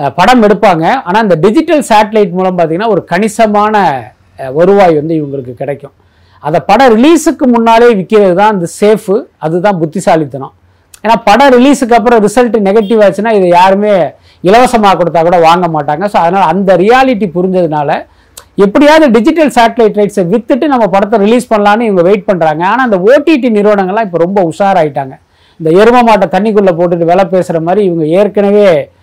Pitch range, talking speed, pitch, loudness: 175-230 Hz, 150 wpm, 205 Hz, -7 LUFS